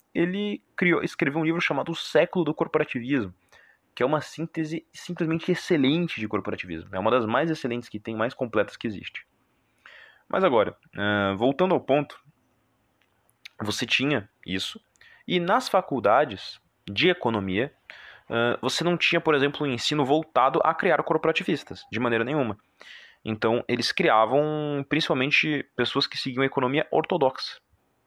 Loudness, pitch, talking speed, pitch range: -25 LUFS, 140 Hz, 140 wpm, 115-160 Hz